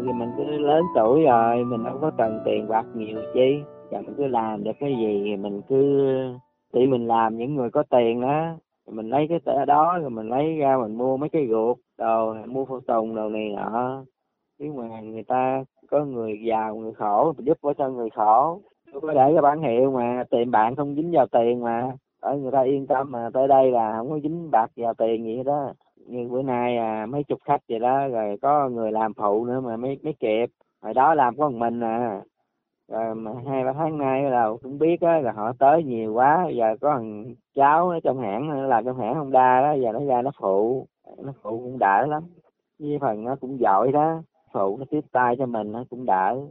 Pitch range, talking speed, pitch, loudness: 115-140 Hz, 230 wpm, 125 Hz, -23 LUFS